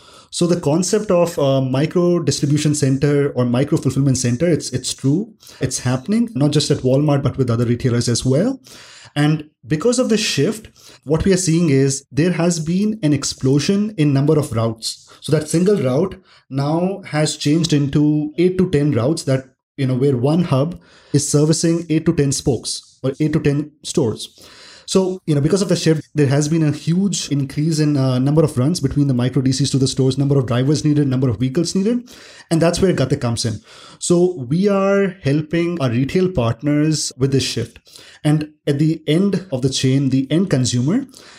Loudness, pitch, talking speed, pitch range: -18 LUFS, 150 Hz, 195 wpm, 135-170 Hz